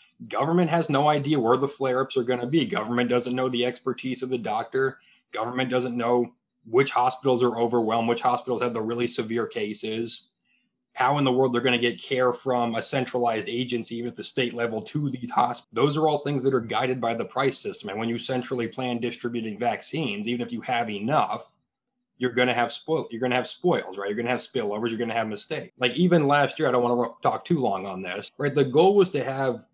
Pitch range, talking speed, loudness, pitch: 120-135 Hz, 240 wpm, -25 LUFS, 125 Hz